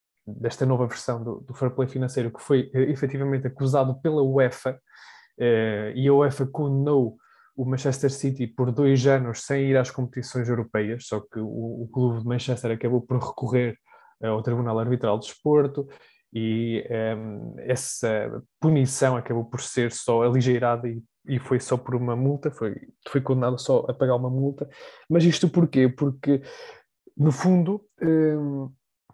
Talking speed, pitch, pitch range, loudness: 155 wpm, 130 Hz, 120-140 Hz, -24 LUFS